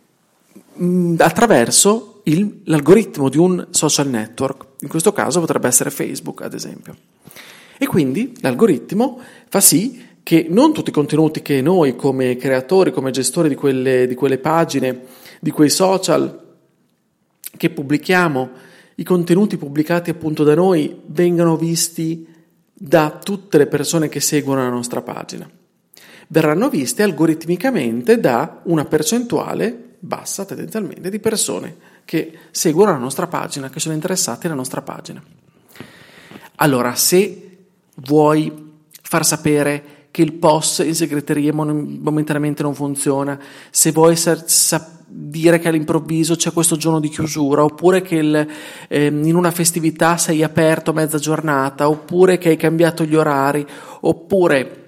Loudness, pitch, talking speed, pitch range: -16 LUFS, 160 Hz, 135 wpm, 150-180 Hz